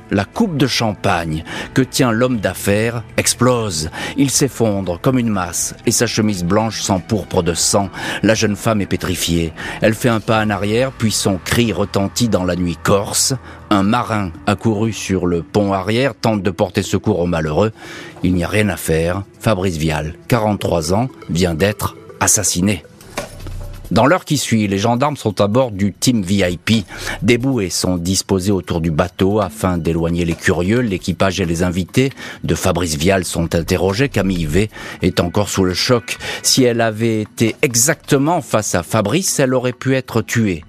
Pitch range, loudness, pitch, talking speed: 90-115 Hz, -17 LUFS, 100 Hz, 175 wpm